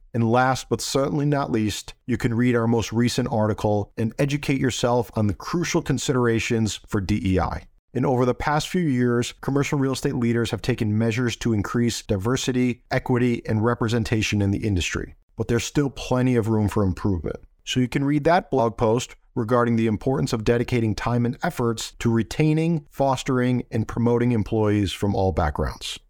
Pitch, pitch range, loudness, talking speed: 120 Hz, 110-130 Hz, -23 LUFS, 175 wpm